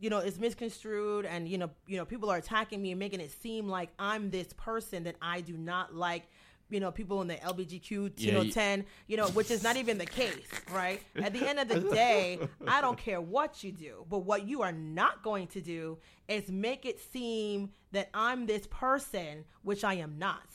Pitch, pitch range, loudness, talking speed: 200 Hz, 180-220 Hz, -34 LUFS, 220 wpm